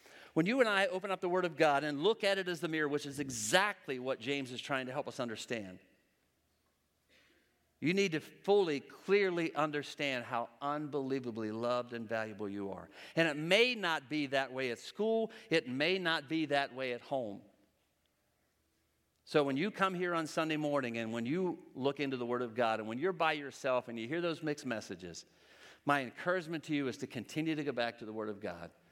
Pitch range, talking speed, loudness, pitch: 120-165 Hz, 210 wpm, -35 LUFS, 145 Hz